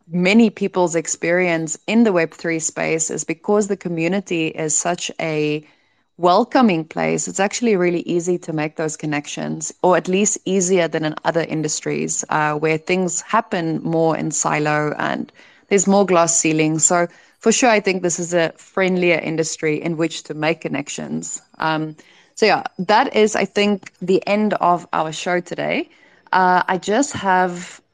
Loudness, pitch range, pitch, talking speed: -19 LUFS, 160-195 Hz, 175 Hz, 165 wpm